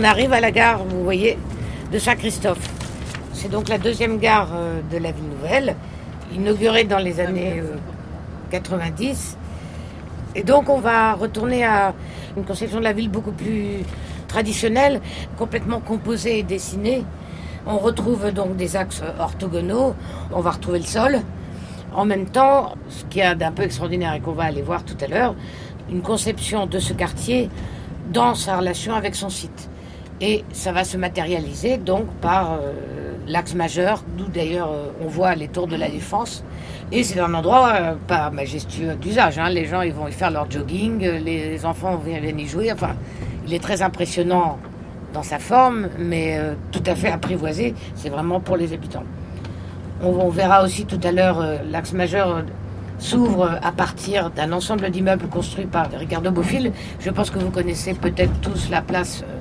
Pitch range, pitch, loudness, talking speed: 165-215 Hz, 185 Hz, -21 LUFS, 175 wpm